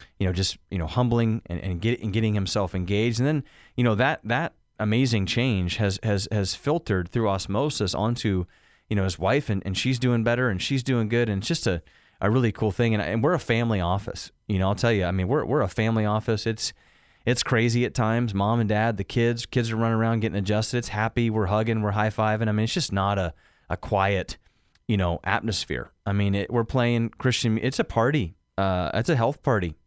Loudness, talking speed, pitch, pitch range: -25 LUFS, 230 wpm, 110 Hz, 100-120 Hz